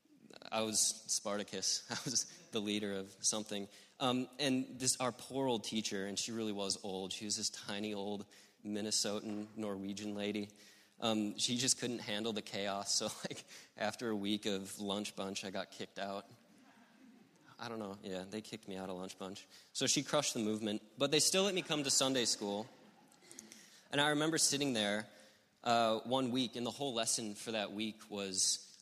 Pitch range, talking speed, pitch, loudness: 100-125 Hz, 185 wpm, 110 Hz, -37 LUFS